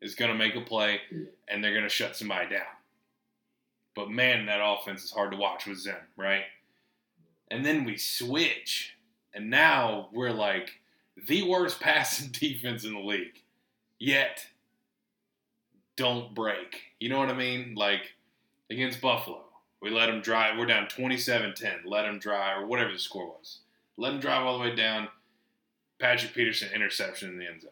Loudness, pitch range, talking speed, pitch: -28 LUFS, 100-125 Hz, 175 wpm, 110 Hz